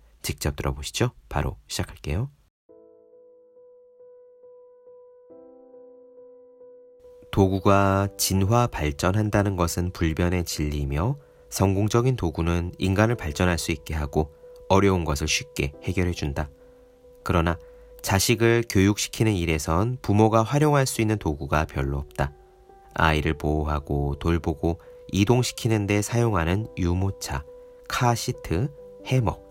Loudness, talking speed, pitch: -24 LUFS, 245 characters per minute, 105 Hz